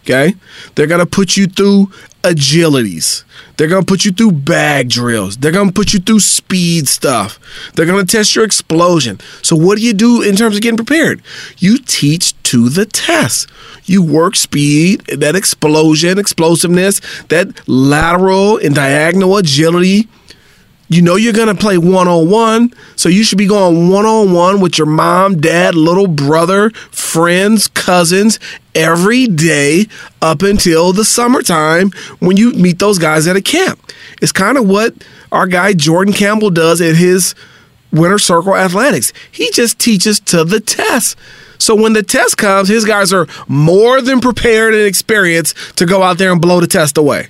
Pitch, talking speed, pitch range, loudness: 185 Hz, 170 wpm, 165-210 Hz, -10 LUFS